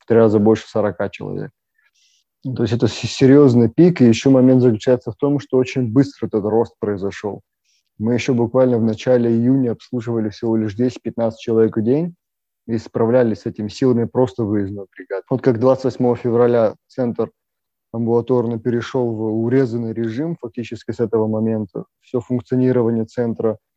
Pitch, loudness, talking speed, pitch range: 120 Hz, -18 LUFS, 155 wpm, 110-125 Hz